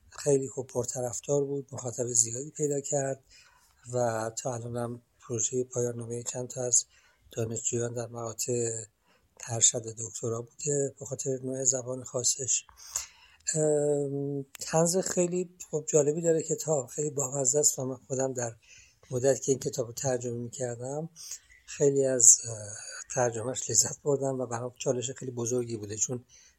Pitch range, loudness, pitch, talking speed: 120-140 Hz, -29 LUFS, 130 Hz, 140 wpm